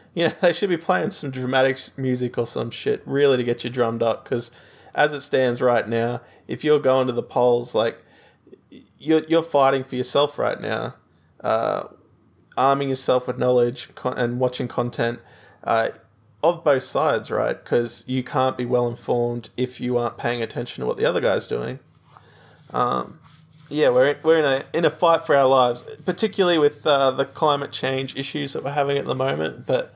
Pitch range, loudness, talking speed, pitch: 120-150 Hz, -22 LUFS, 190 wpm, 130 Hz